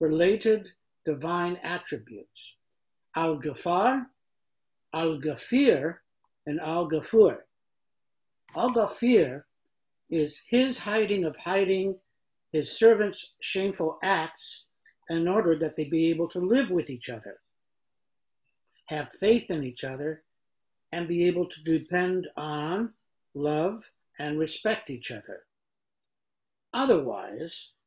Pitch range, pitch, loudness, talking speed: 155-205 Hz, 170 Hz, -27 LUFS, 105 wpm